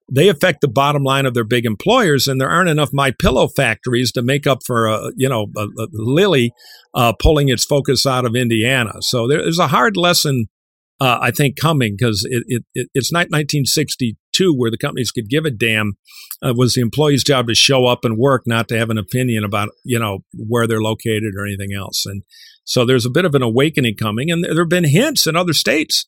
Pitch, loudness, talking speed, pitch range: 125 Hz, -16 LUFS, 220 wpm, 115-145 Hz